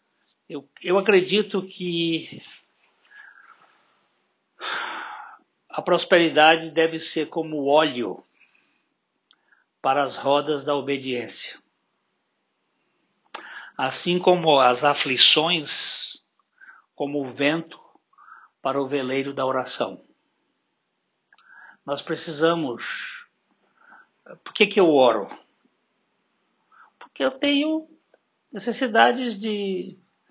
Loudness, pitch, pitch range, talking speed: -22 LUFS, 165 Hz, 145-215 Hz, 75 wpm